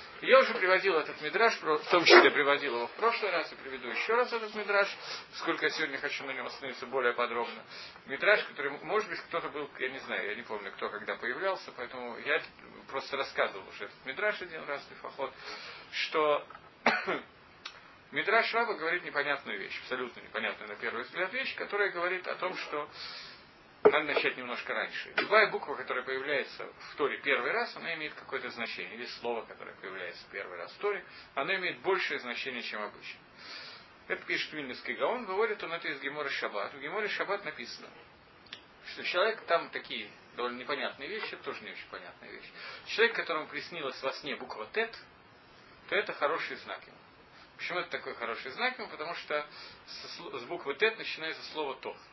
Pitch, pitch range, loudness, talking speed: 160 Hz, 135-210 Hz, -32 LUFS, 175 wpm